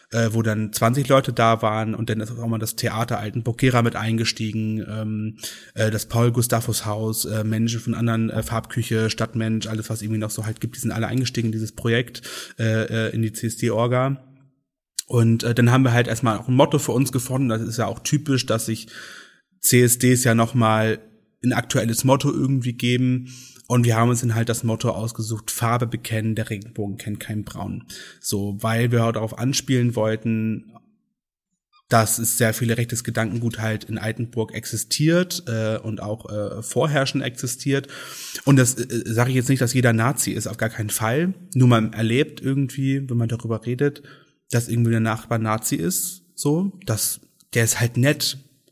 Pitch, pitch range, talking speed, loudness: 115 Hz, 110-125 Hz, 185 wpm, -22 LUFS